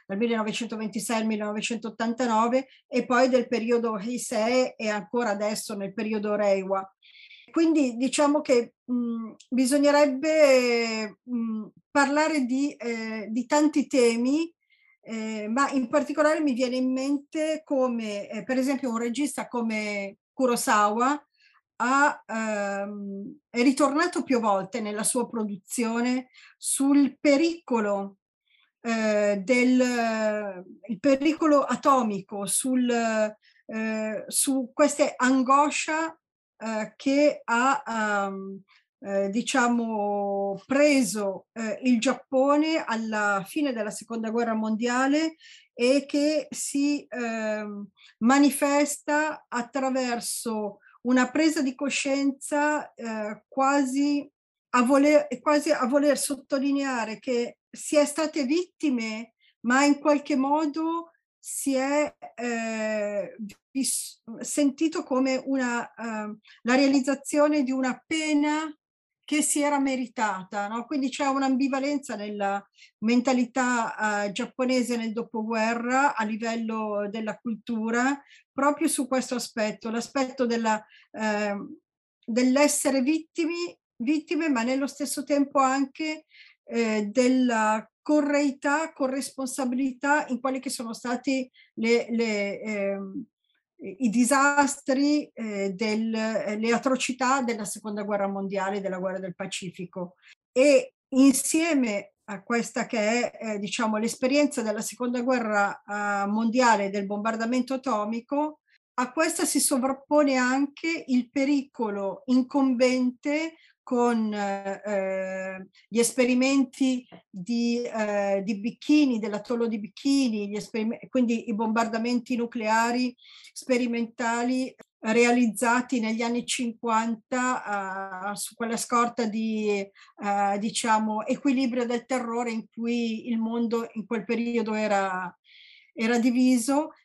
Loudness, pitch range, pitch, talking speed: -26 LUFS, 220-280 Hz, 245 Hz, 110 wpm